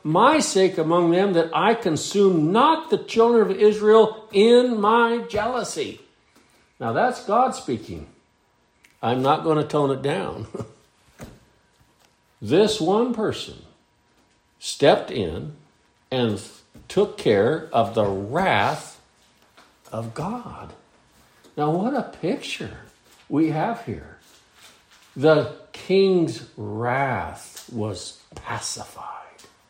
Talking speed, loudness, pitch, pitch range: 105 wpm, -21 LUFS, 170 Hz, 135-215 Hz